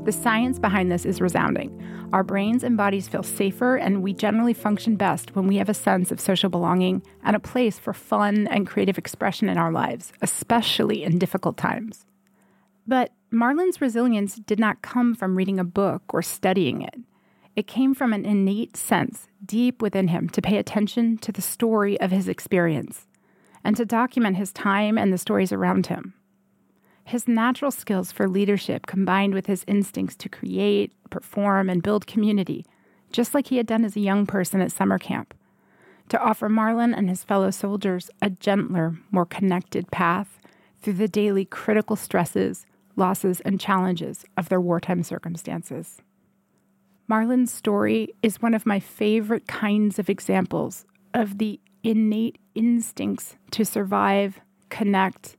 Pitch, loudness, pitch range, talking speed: 200 Hz, -23 LUFS, 190-220 Hz, 160 wpm